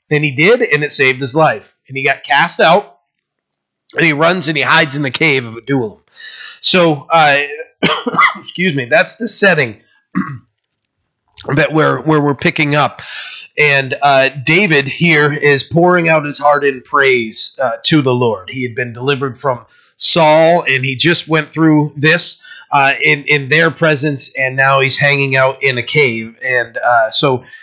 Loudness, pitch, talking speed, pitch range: -12 LUFS, 145 Hz, 175 wpm, 135-160 Hz